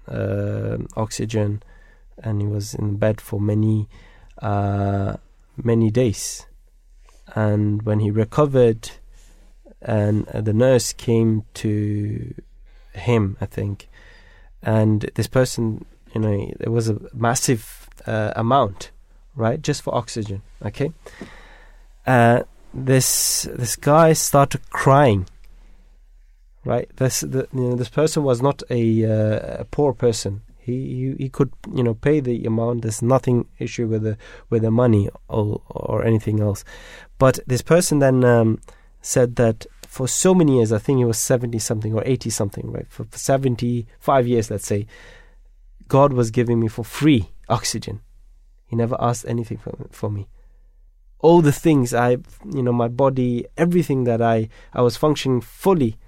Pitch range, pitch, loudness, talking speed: 105-130 Hz, 115 Hz, -20 LUFS, 150 wpm